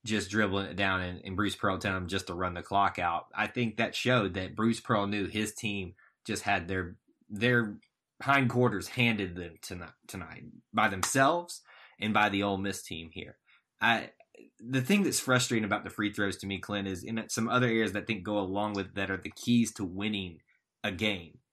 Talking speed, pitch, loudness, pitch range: 205 wpm, 105 Hz, -30 LUFS, 95-115 Hz